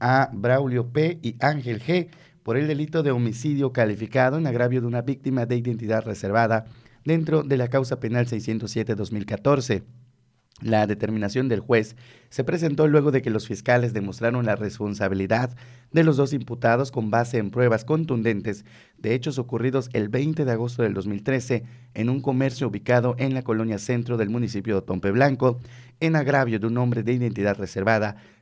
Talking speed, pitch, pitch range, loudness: 165 wpm, 120 Hz, 110-135 Hz, -24 LUFS